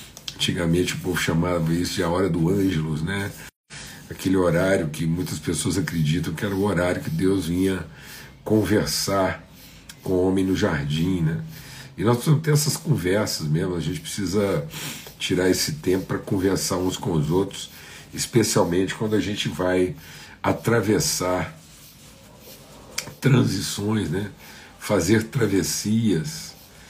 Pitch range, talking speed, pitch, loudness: 85-105 Hz, 135 wpm, 95 Hz, -23 LUFS